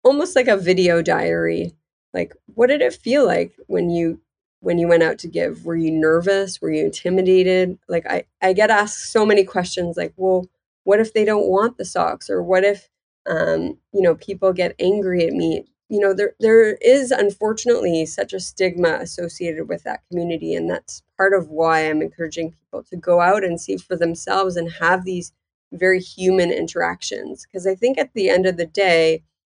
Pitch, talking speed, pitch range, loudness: 185 Hz, 195 wpm, 170-200 Hz, -19 LUFS